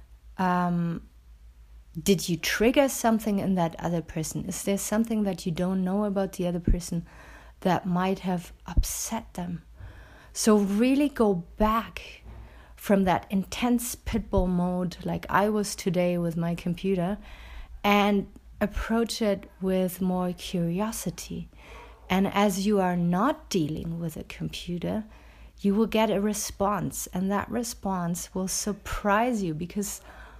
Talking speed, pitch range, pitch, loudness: 135 wpm, 175-210 Hz, 190 Hz, -27 LUFS